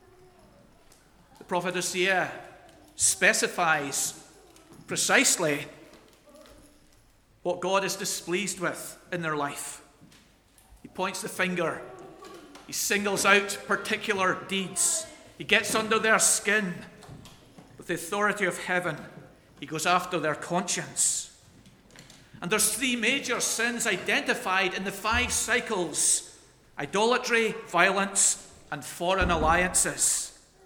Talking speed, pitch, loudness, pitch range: 100 wpm, 195 Hz, -26 LUFS, 175-220 Hz